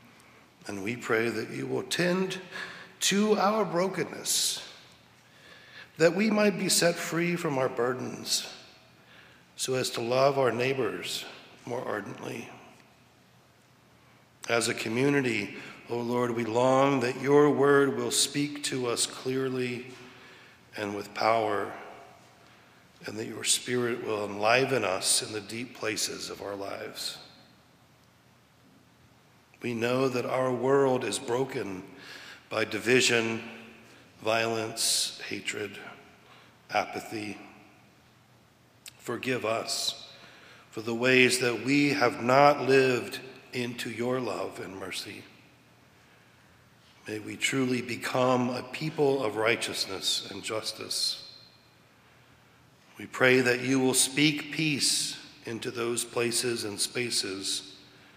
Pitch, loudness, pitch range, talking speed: 125 Hz, -28 LUFS, 115-135 Hz, 110 wpm